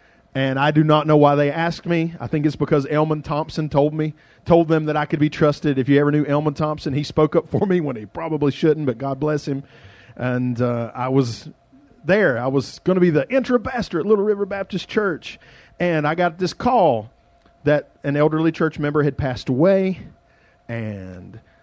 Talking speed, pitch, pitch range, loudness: 205 wpm, 150 Hz, 135-165 Hz, -20 LUFS